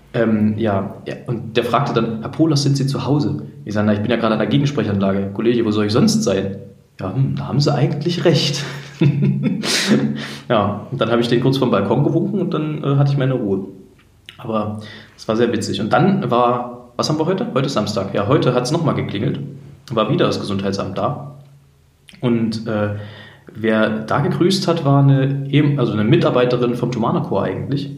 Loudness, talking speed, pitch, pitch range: -18 LUFS, 200 wpm, 120 Hz, 105-140 Hz